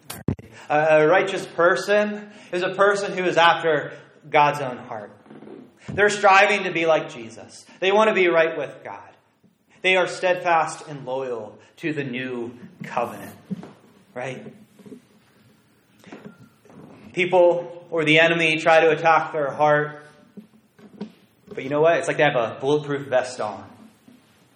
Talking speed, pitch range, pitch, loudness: 135 wpm, 150-190 Hz, 165 Hz, -20 LUFS